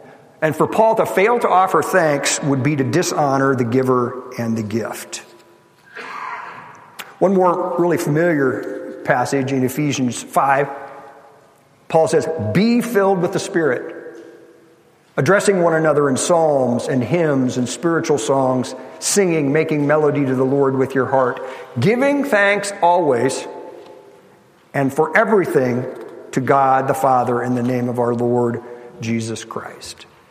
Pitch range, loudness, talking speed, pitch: 130-170 Hz, -17 LUFS, 135 wpm, 140 Hz